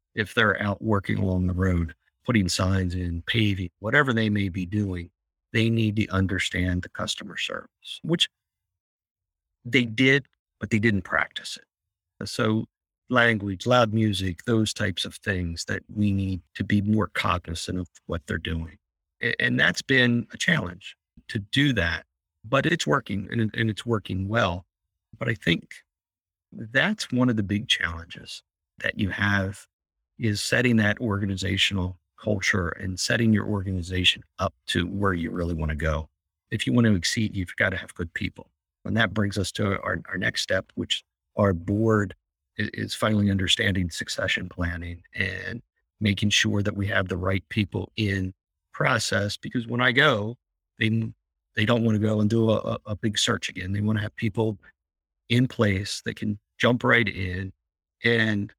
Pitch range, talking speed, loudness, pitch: 90-110 Hz, 165 wpm, -25 LUFS, 100 Hz